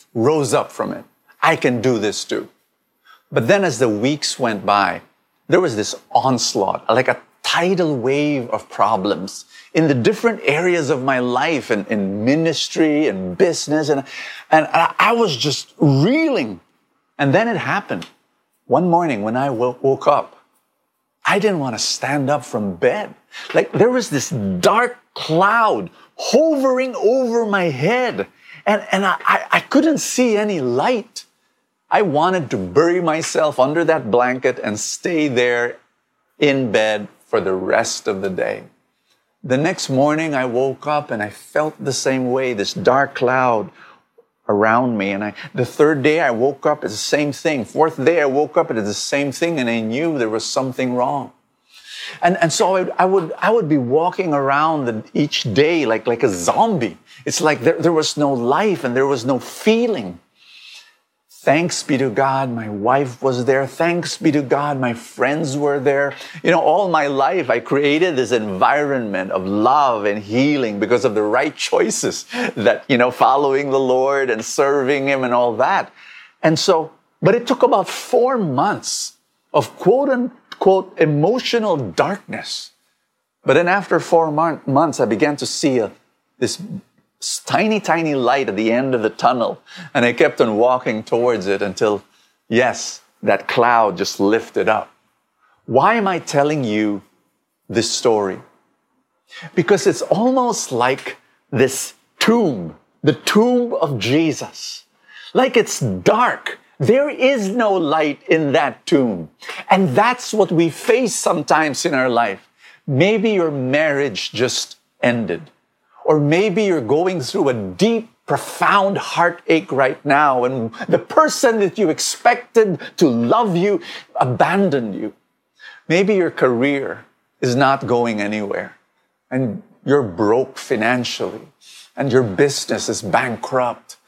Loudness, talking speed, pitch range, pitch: -17 LUFS, 160 wpm, 125-180 Hz, 145 Hz